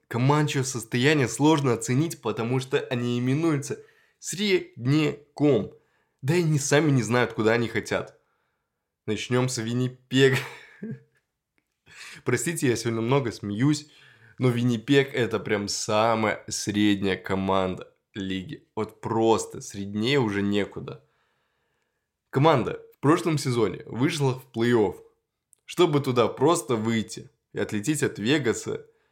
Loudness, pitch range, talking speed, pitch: -25 LUFS, 110-150 Hz, 110 wpm, 125 Hz